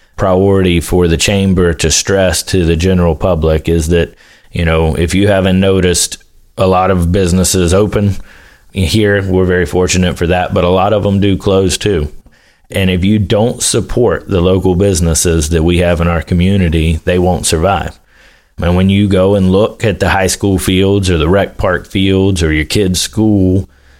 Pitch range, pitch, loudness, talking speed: 85-95 Hz, 90 Hz, -11 LUFS, 185 wpm